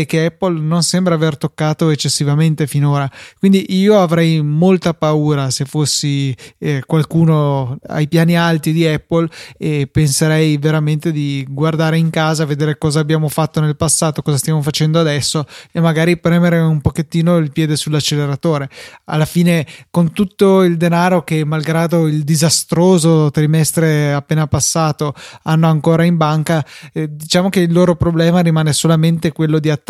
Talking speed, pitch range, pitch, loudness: 150 wpm, 150-165 Hz, 160 Hz, -14 LUFS